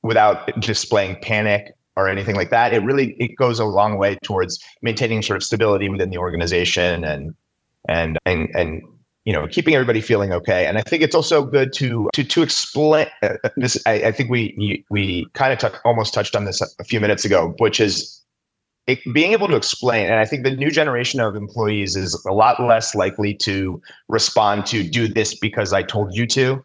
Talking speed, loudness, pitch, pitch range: 205 wpm, -19 LUFS, 110 Hz, 95-125 Hz